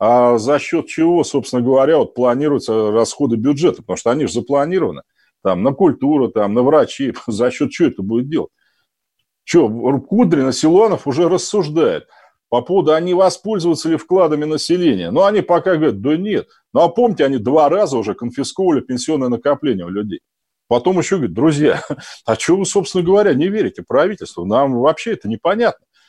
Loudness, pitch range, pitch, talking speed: -16 LUFS, 130-190 Hz, 160 Hz, 170 wpm